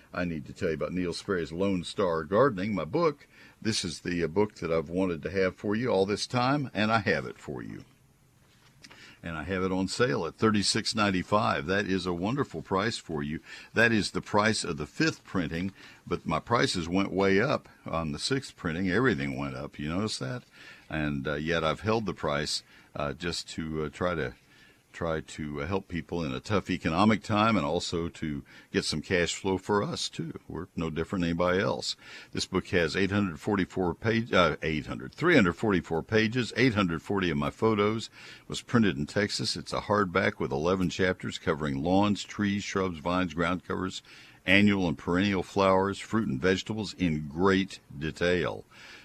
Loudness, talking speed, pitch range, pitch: -29 LUFS, 185 wpm, 80-105 Hz, 95 Hz